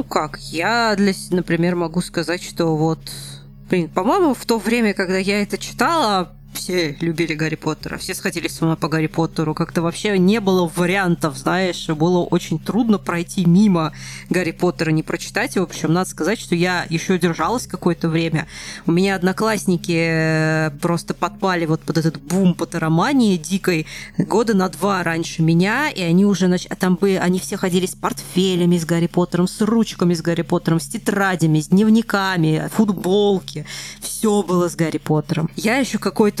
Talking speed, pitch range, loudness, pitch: 170 wpm, 165-195 Hz, -19 LUFS, 175 Hz